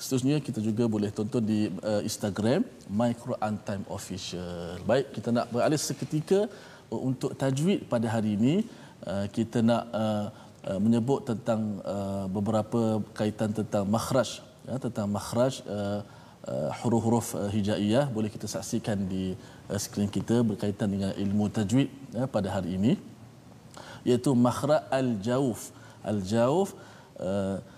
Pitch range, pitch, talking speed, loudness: 105-125 Hz, 110 Hz, 130 wpm, -29 LUFS